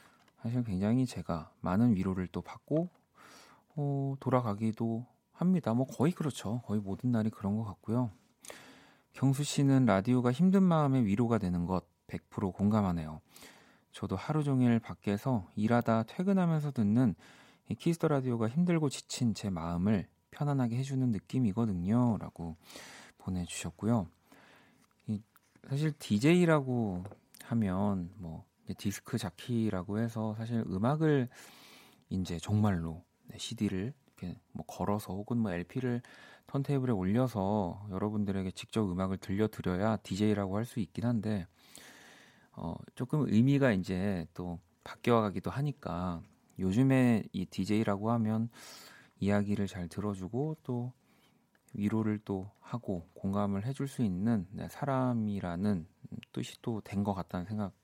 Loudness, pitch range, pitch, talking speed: -33 LUFS, 95-125 Hz, 110 Hz, 280 characters per minute